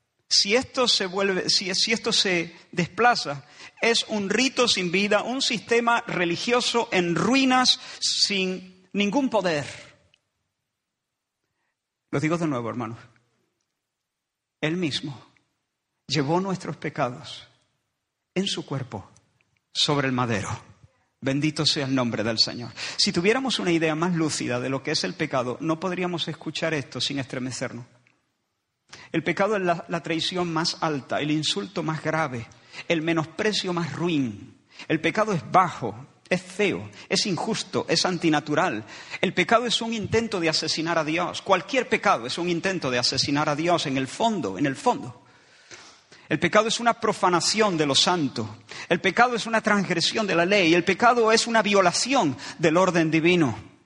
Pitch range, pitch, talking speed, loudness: 145-200 Hz, 170 Hz, 150 wpm, -23 LUFS